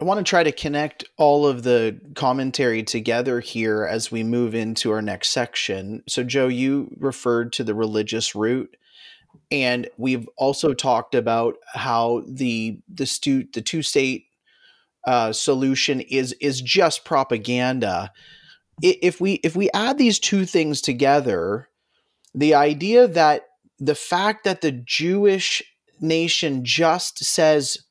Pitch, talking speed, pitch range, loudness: 135 Hz, 140 wpm, 120-160 Hz, -21 LUFS